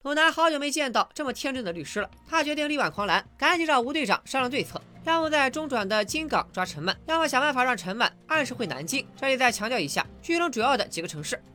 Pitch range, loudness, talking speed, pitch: 210-305 Hz, -26 LUFS, 375 characters per minute, 265 Hz